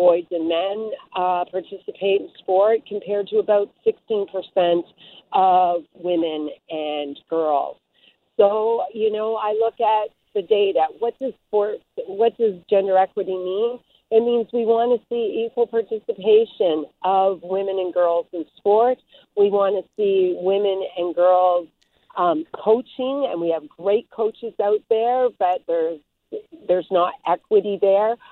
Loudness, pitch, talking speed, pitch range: -21 LUFS, 205 Hz, 140 wpm, 180-235 Hz